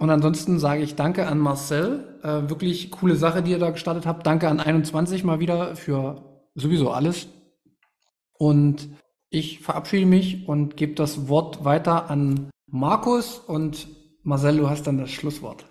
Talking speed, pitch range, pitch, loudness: 160 wpm, 145-170 Hz, 155 Hz, -23 LUFS